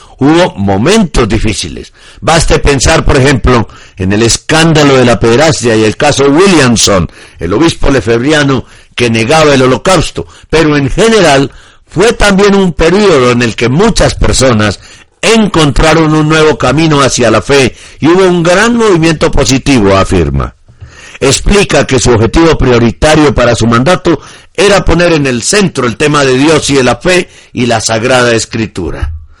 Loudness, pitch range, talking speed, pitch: -7 LUFS, 115-160 Hz, 155 wpm, 130 Hz